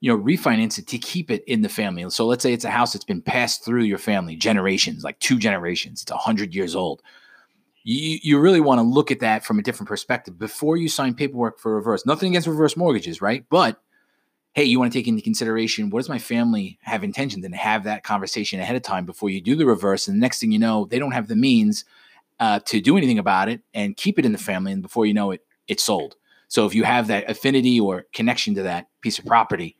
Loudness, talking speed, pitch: -21 LUFS, 250 wpm, 140 Hz